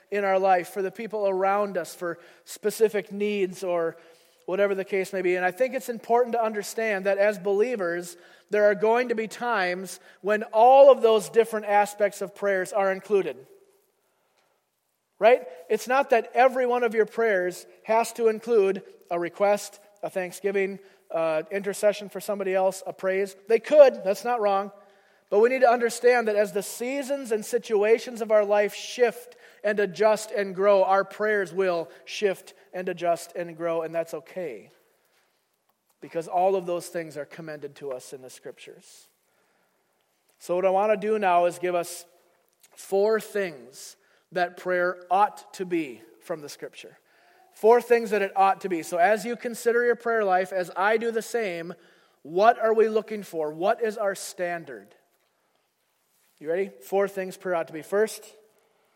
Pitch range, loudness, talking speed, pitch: 180-225 Hz, -25 LUFS, 175 wpm, 200 Hz